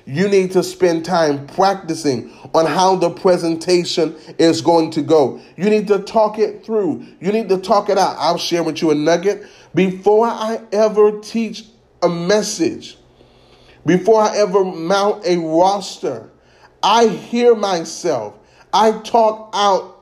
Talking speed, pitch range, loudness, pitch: 150 wpm, 170-215 Hz, -16 LUFS, 195 Hz